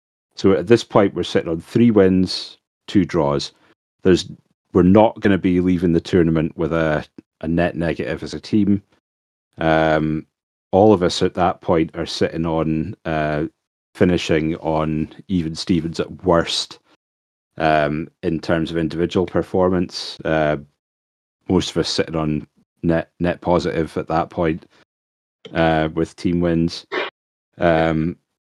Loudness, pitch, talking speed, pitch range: -19 LUFS, 80 Hz, 145 wpm, 75-90 Hz